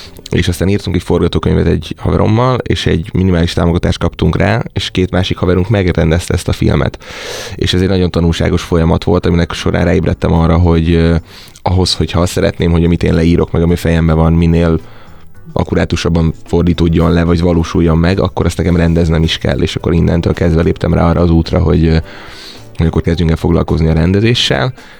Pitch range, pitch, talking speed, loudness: 80-90 Hz, 85 Hz, 180 wpm, -12 LUFS